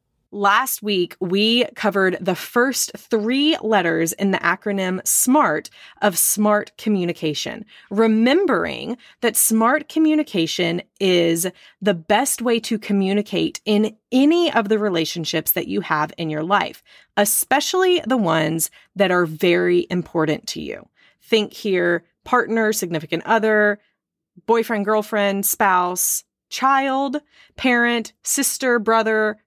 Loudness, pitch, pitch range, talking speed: -19 LUFS, 210 Hz, 180-240 Hz, 115 wpm